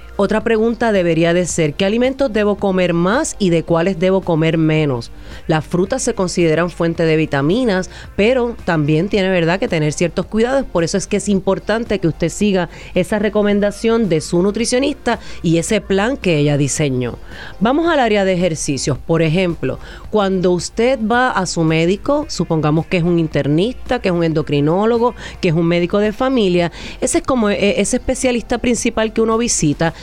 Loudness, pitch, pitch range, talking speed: -16 LUFS, 190 Hz, 165-225 Hz, 175 wpm